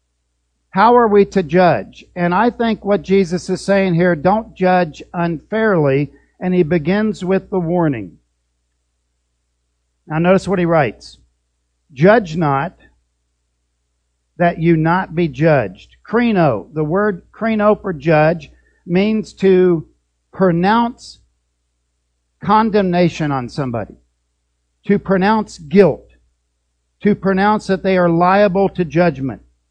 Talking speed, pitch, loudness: 115 wpm, 170 Hz, -15 LUFS